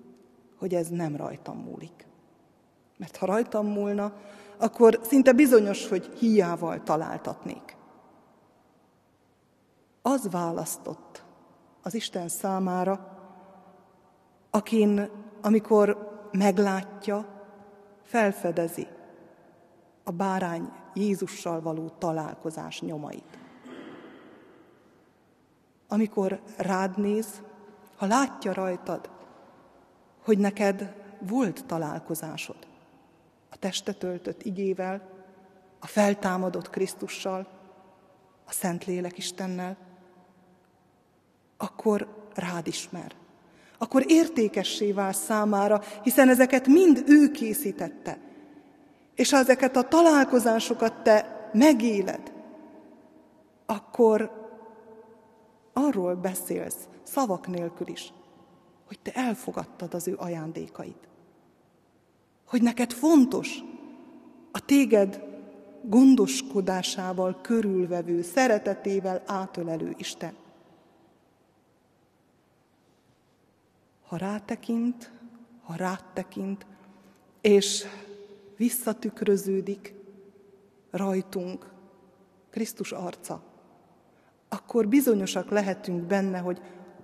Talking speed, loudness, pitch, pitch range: 75 wpm, -26 LUFS, 200 Hz, 185-225 Hz